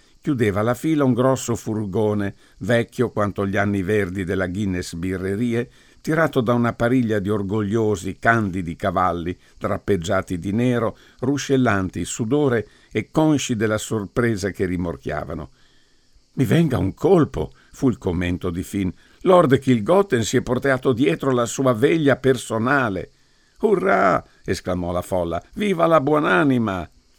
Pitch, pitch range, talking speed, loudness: 110 Hz, 95-130 Hz, 130 wpm, -21 LUFS